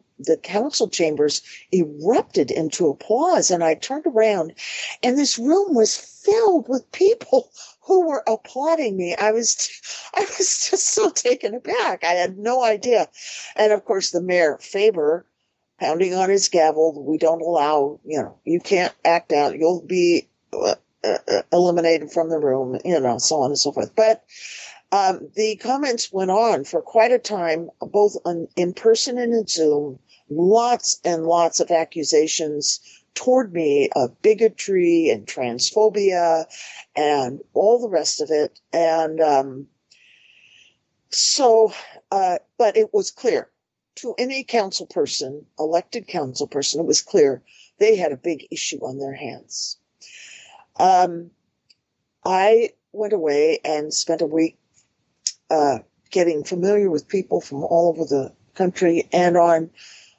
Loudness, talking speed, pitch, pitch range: -20 LUFS, 145 wpm, 185 Hz, 160-245 Hz